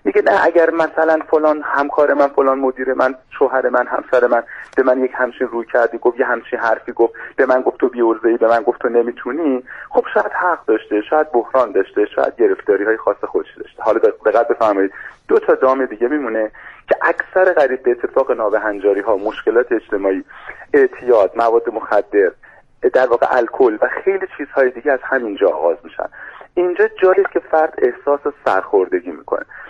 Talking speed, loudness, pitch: 180 wpm, -16 LUFS, 160 Hz